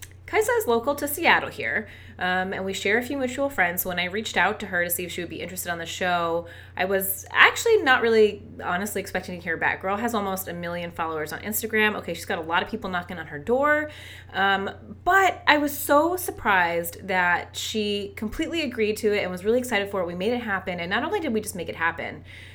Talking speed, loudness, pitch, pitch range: 240 wpm, -24 LUFS, 195 Hz, 175-235 Hz